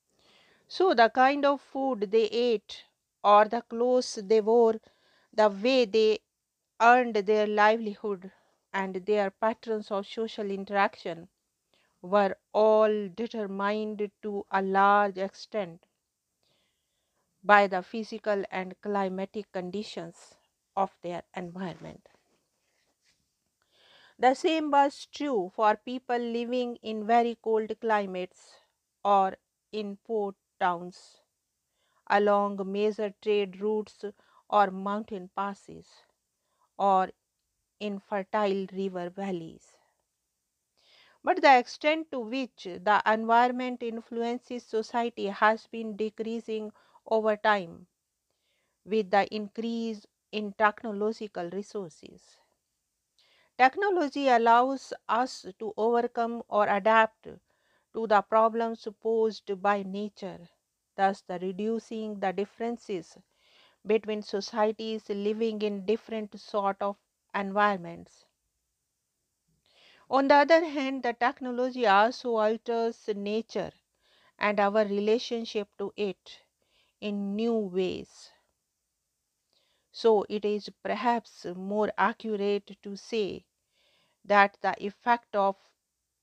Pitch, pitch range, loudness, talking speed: 215 Hz, 200-230 Hz, -28 LUFS, 100 wpm